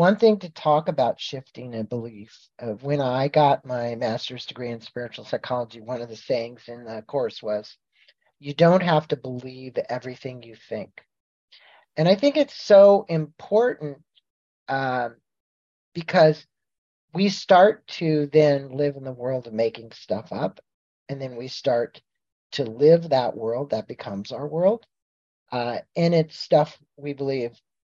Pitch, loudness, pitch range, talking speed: 135 Hz, -23 LUFS, 120-155 Hz, 155 wpm